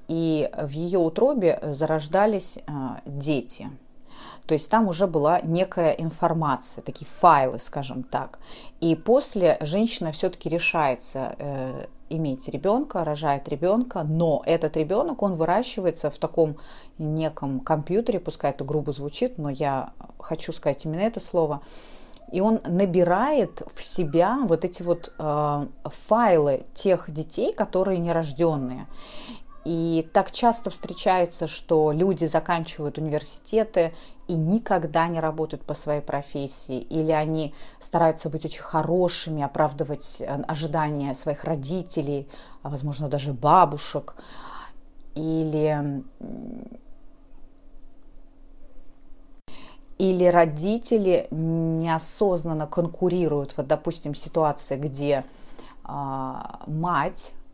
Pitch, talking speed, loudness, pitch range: 165 Hz, 105 wpm, -25 LUFS, 150-185 Hz